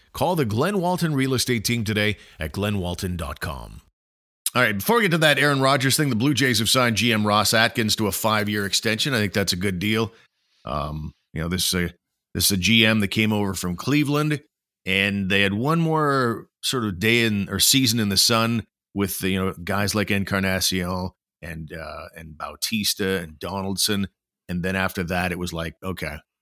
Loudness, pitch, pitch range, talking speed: -21 LUFS, 100 Hz, 95-115 Hz, 200 wpm